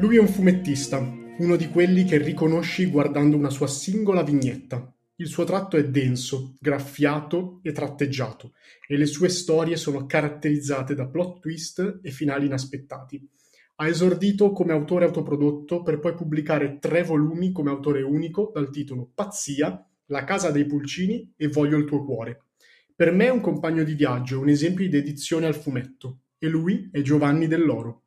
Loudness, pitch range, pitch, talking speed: -24 LUFS, 140-170 Hz, 150 Hz, 165 wpm